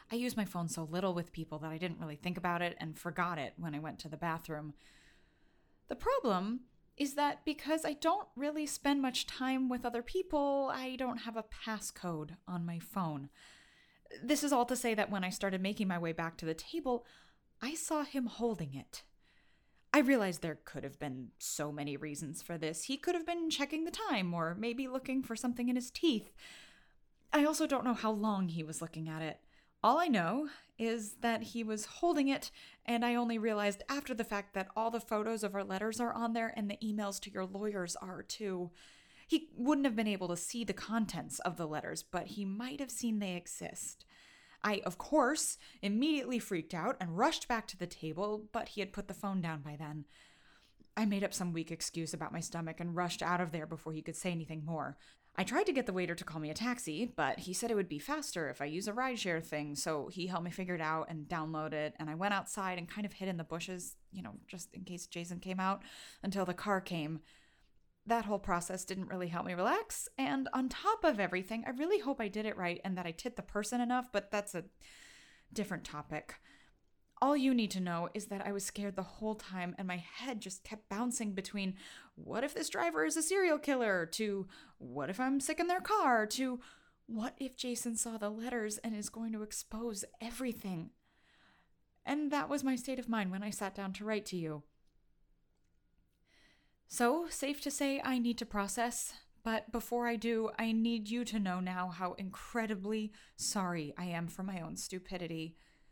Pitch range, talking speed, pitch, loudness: 175-245 Hz, 215 wpm, 205 Hz, -37 LUFS